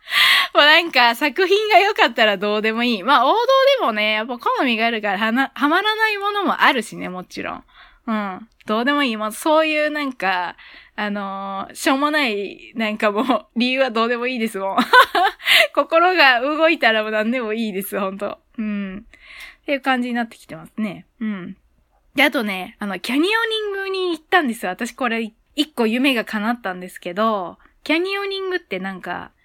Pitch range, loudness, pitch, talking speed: 215-315 Hz, -18 LUFS, 245 Hz, 365 characters per minute